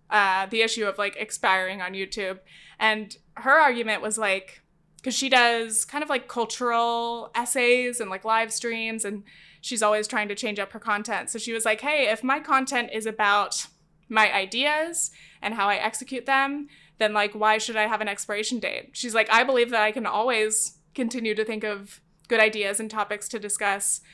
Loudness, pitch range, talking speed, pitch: -24 LUFS, 205-235 Hz, 195 wpm, 220 Hz